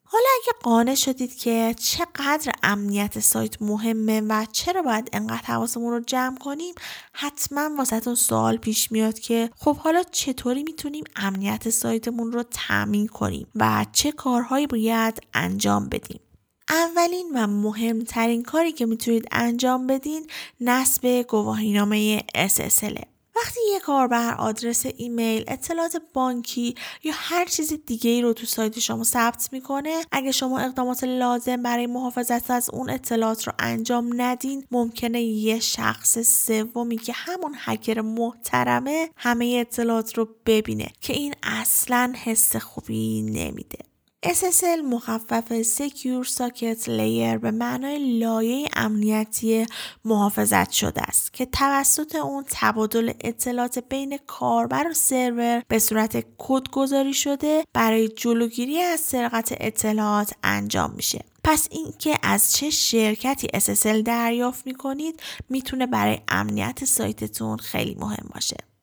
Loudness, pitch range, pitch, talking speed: -23 LUFS, 220-270 Hz, 240 Hz, 125 wpm